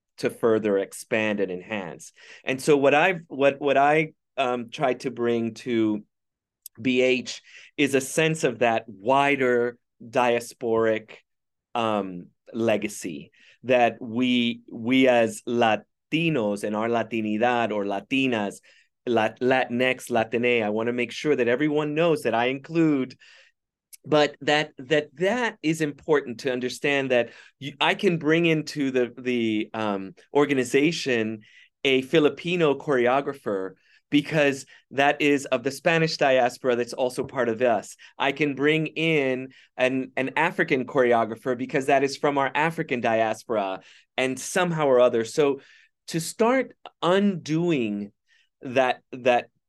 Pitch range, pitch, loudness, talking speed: 115-150 Hz, 130 Hz, -24 LUFS, 130 wpm